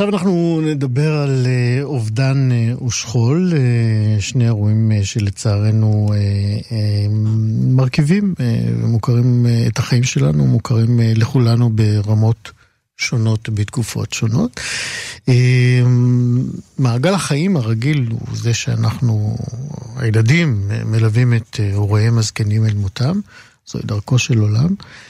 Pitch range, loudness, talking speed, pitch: 110-130 Hz, -16 LUFS, 90 wpm, 115 Hz